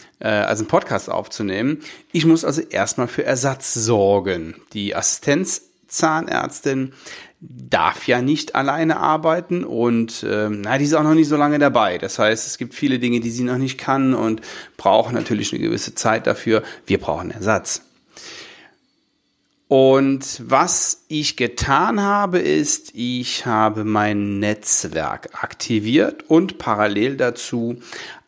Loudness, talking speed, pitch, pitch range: -19 LUFS, 135 wpm, 130 Hz, 115-155 Hz